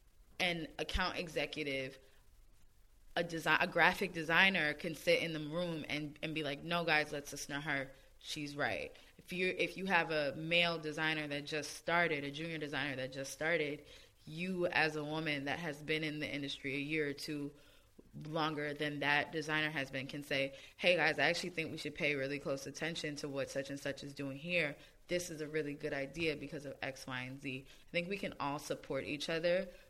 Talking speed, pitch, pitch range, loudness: 205 wpm, 150 Hz, 140-165 Hz, -37 LUFS